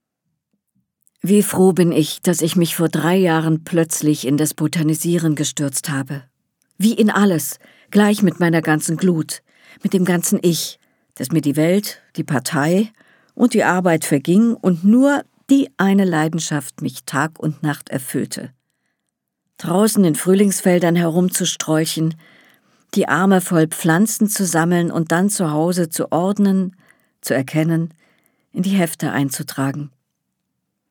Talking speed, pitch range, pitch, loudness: 135 wpm, 155-195 Hz, 170 Hz, -17 LUFS